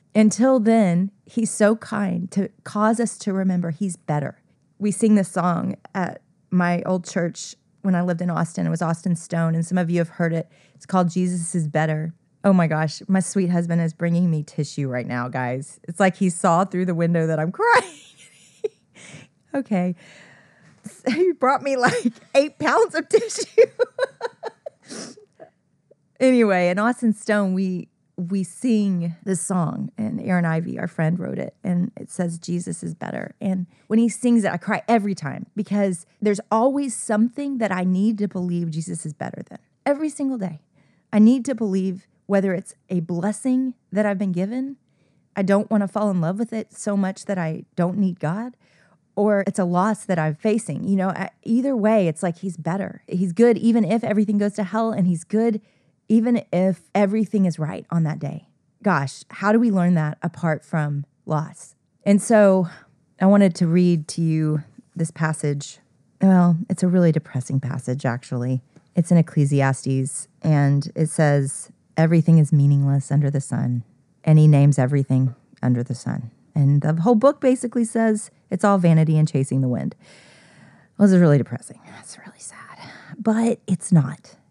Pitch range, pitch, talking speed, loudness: 160-215 Hz, 185 Hz, 180 wpm, -21 LUFS